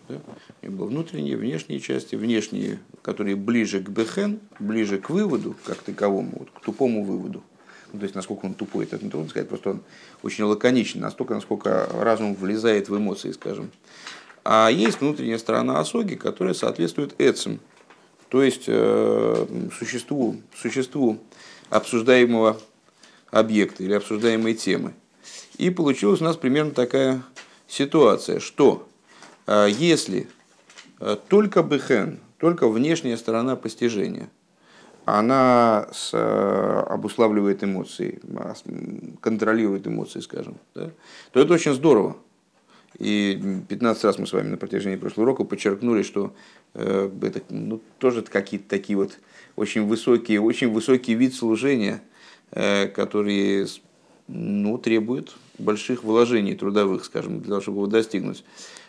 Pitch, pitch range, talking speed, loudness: 110 Hz, 100-125 Hz, 120 wpm, -23 LUFS